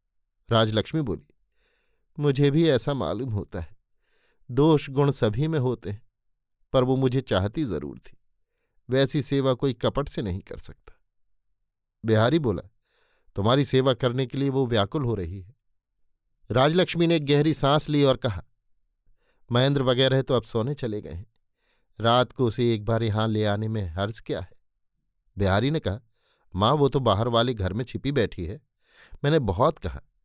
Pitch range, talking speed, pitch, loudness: 100-140 Hz, 165 wpm, 120 Hz, -24 LUFS